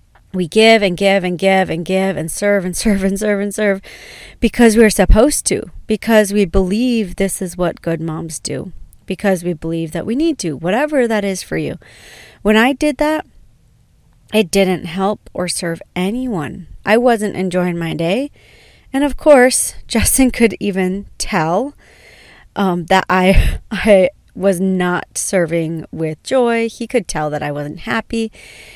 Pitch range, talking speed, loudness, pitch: 180-225 Hz, 165 wpm, -16 LUFS, 195 Hz